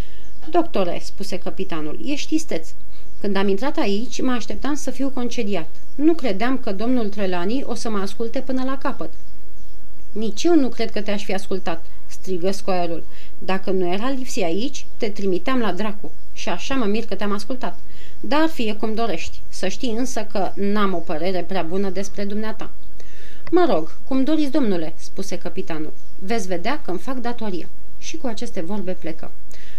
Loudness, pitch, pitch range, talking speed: -25 LUFS, 210 Hz, 185-255 Hz, 170 wpm